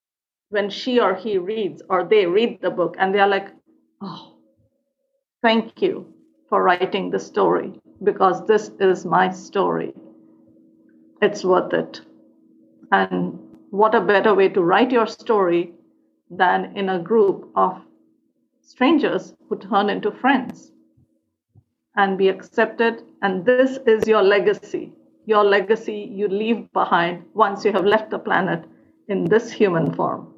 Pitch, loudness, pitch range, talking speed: 205 Hz, -20 LUFS, 185-230 Hz, 140 wpm